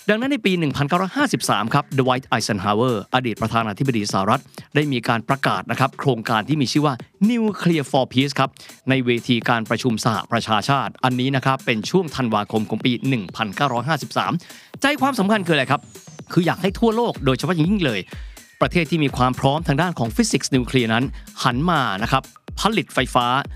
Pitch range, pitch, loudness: 120-160 Hz, 135 Hz, -20 LUFS